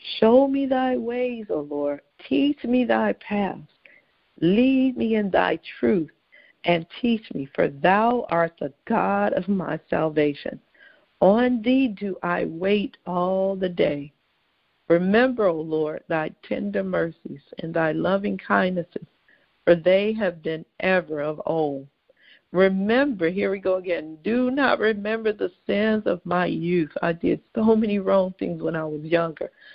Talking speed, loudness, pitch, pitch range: 150 wpm, -23 LUFS, 190 Hz, 165-220 Hz